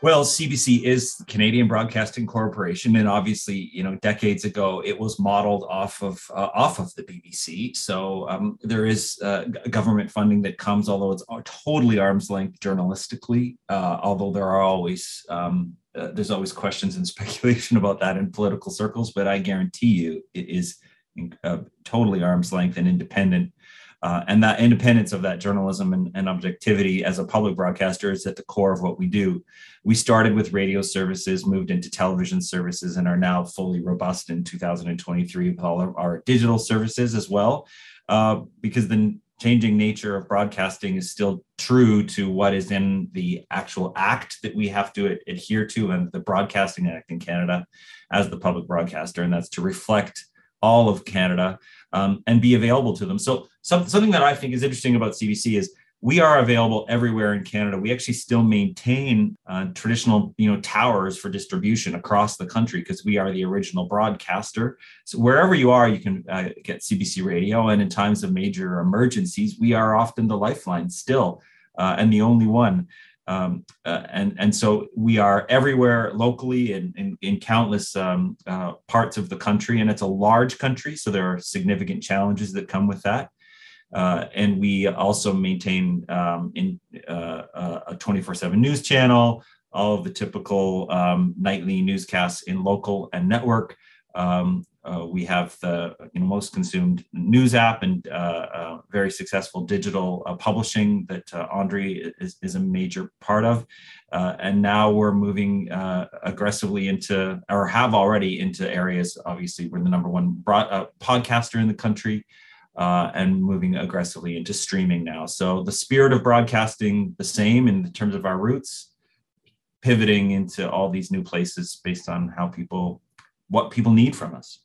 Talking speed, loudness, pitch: 175 wpm, -22 LUFS, 110 Hz